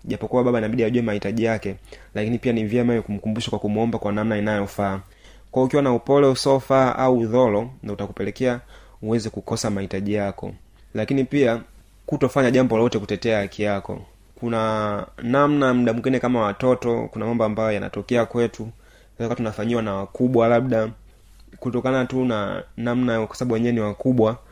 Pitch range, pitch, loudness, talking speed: 105-125 Hz, 115 Hz, -22 LUFS, 130 wpm